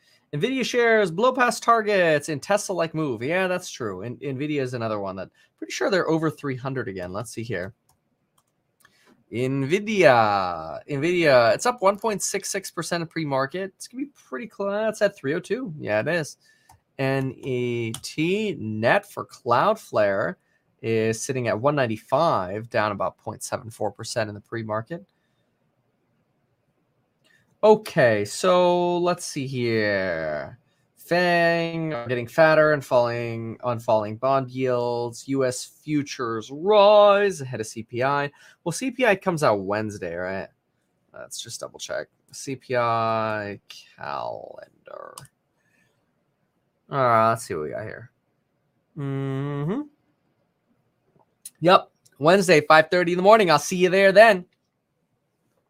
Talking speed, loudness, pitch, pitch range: 125 wpm, -22 LUFS, 145 Hz, 120-190 Hz